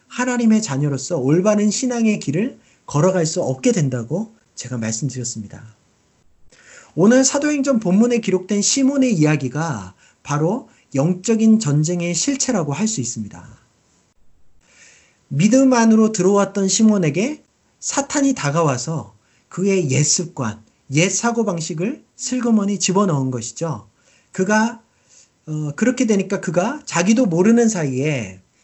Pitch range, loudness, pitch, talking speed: 145-225 Hz, -18 LUFS, 185 Hz, 280 characters per minute